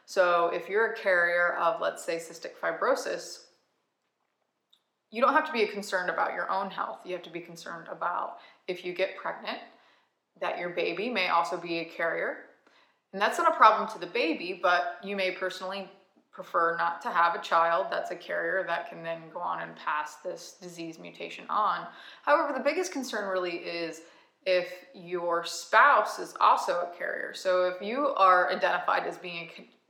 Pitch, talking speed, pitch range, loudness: 180 Hz, 185 wpm, 170-205 Hz, -28 LUFS